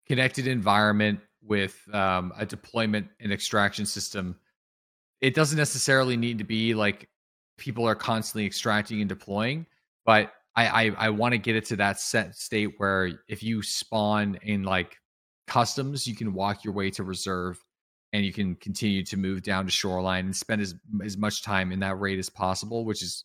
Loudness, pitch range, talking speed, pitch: -27 LUFS, 95-110 Hz, 180 wpm, 105 Hz